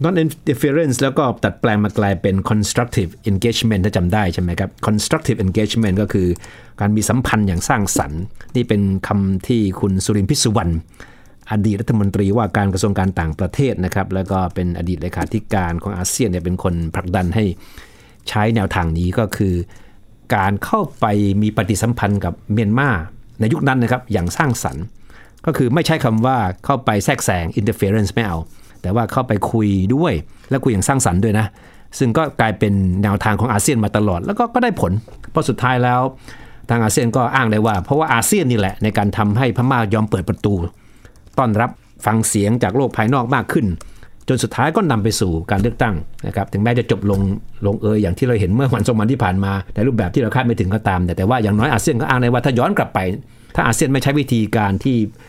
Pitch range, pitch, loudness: 100-120 Hz, 110 Hz, -18 LUFS